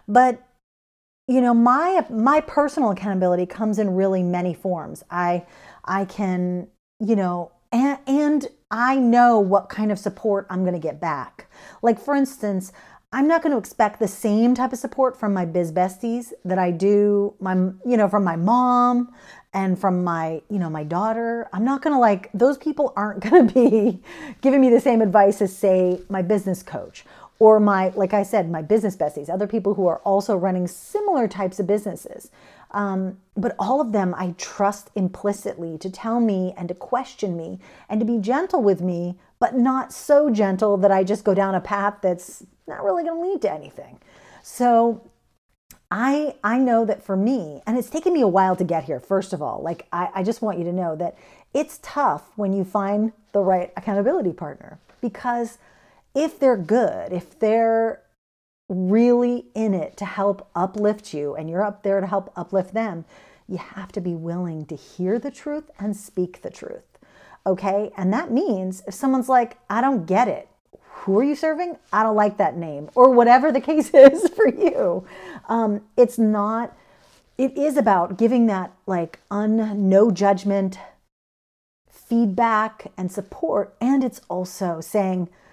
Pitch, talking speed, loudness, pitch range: 205 Hz, 180 wpm, -21 LUFS, 185-245 Hz